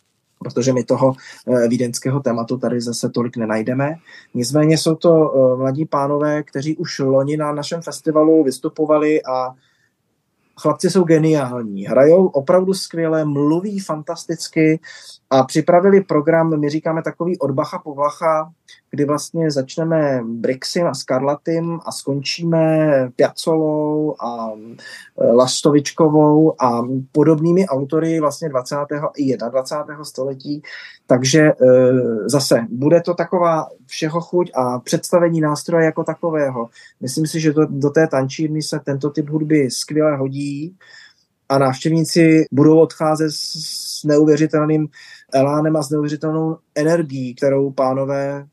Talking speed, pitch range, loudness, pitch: 120 wpm, 135-160 Hz, -17 LUFS, 150 Hz